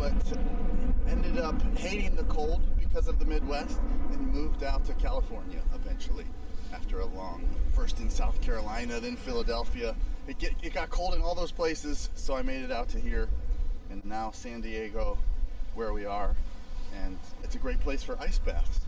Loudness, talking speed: -34 LUFS, 180 wpm